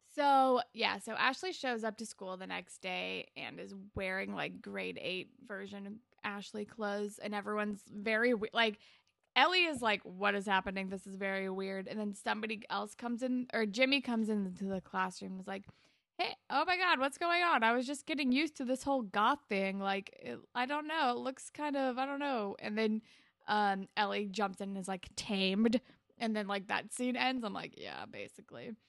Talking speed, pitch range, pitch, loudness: 210 wpm, 195-255 Hz, 215 Hz, -35 LUFS